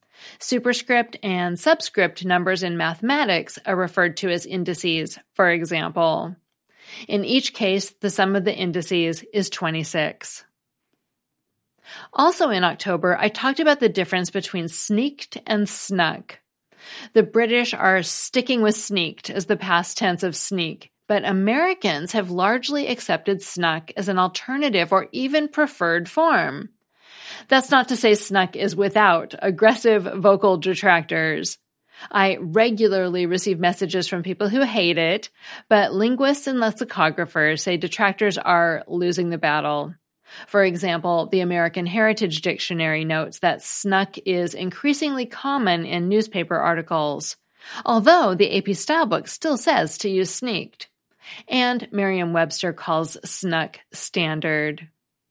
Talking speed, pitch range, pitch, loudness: 130 wpm, 175-225 Hz, 190 Hz, -21 LUFS